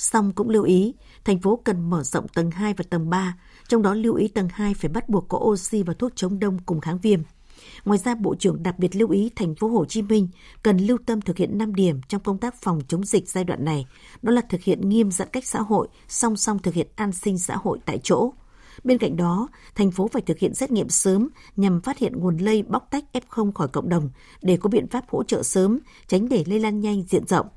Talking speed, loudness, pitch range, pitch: 250 wpm, -23 LUFS, 180-220 Hz, 205 Hz